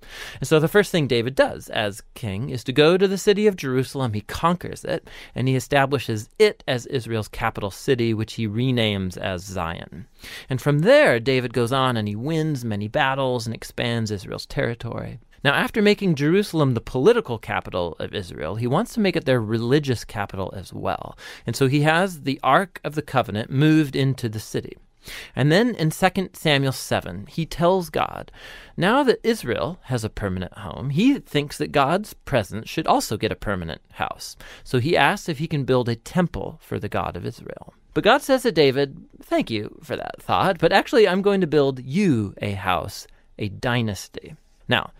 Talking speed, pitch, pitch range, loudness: 190 wpm, 135 Hz, 110-165 Hz, -22 LUFS